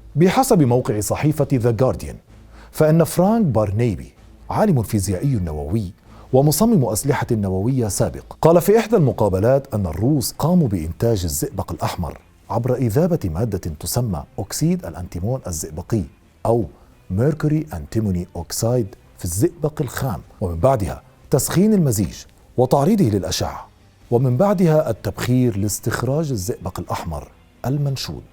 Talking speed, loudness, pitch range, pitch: 110 wpm, -20 LUFS, 95-145 Hz, 120 Hz